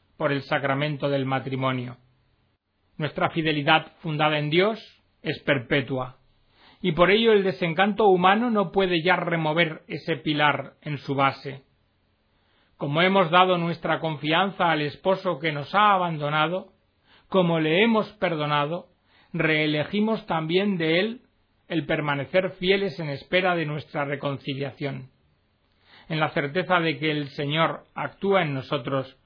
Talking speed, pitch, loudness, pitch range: 130 wpm, 155 Hz, -24 LUFS, 140-180 Hz